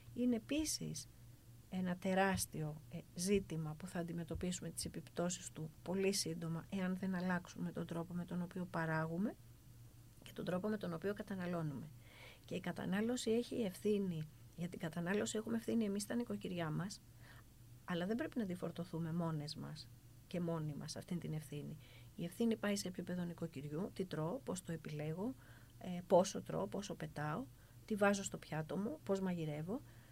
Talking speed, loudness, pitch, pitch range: 155 wpm, -42 LUFS, 170 Hz, 150-195 Hz